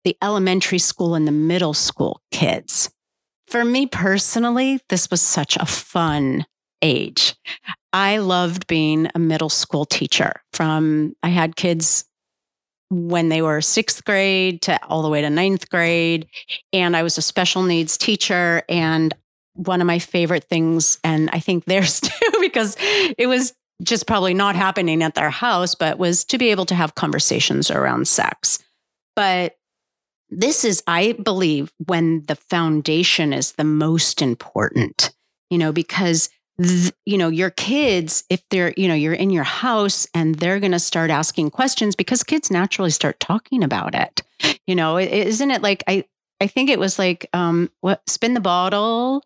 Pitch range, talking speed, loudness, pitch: 165-200 Hz, 165 wpm, -18 LUFS, 180 Hz